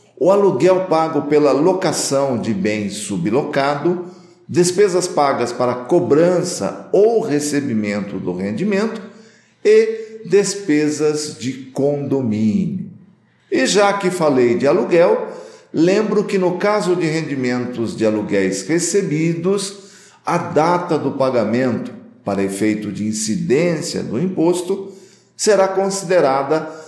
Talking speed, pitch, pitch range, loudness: 105 wpm, 170 Hz, 135-195 Hz, -17 LUFS